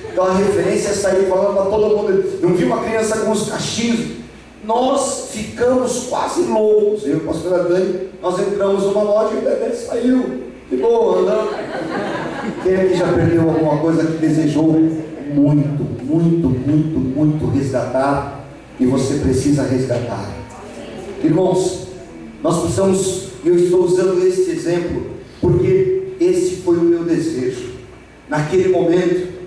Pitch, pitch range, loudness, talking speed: 185 Hz, 160-230 Hz, -17 LUFS, 135 wpm